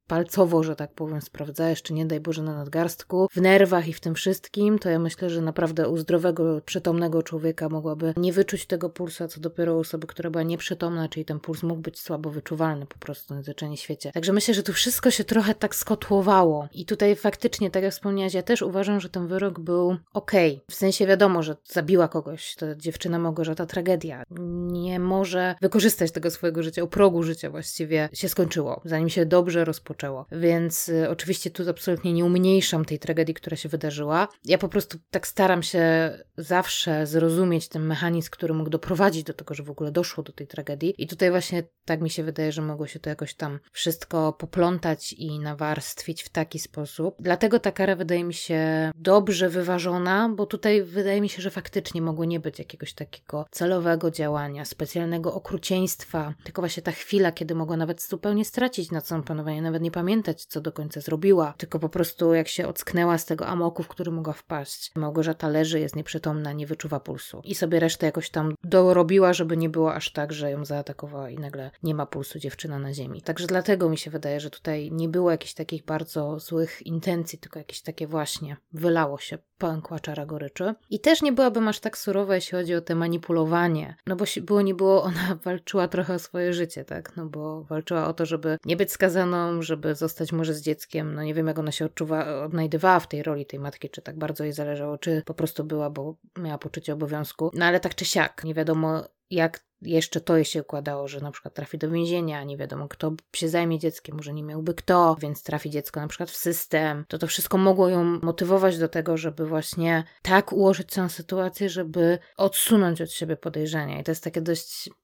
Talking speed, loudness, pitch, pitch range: 200 wpm, -25 LUFS, 165 Hz, 155-180 Hz